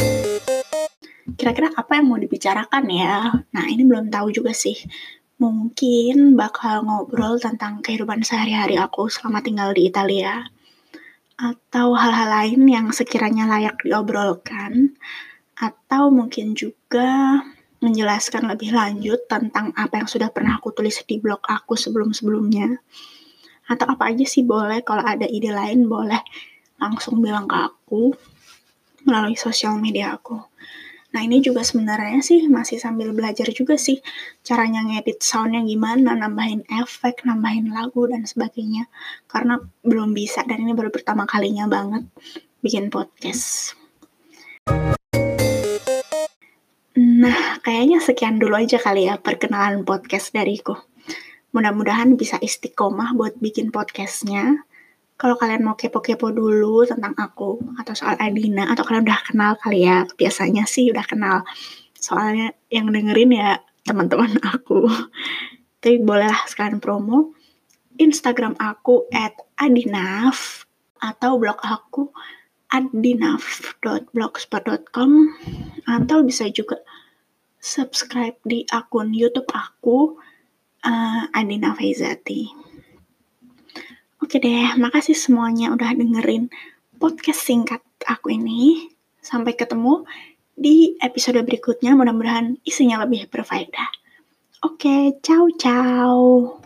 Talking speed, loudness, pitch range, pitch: 115 wpm, -19 LUFS, 220-260 Hz, 235 Hz